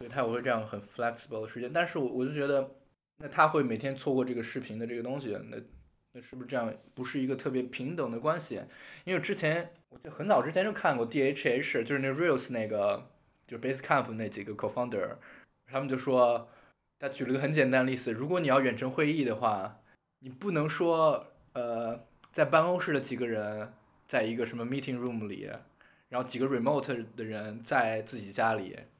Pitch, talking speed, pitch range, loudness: 130 Hz, 365 characters per minute, 115-140 Hz, -31 LUFS